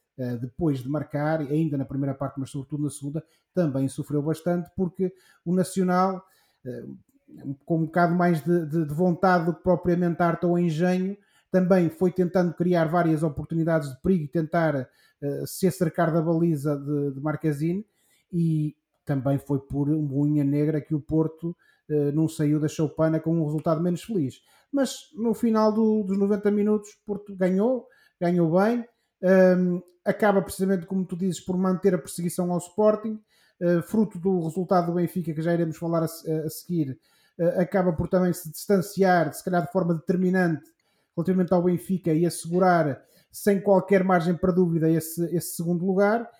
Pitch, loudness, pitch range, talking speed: 175 Hz, -25 LUFS, 155-185 Hz, 165 wpm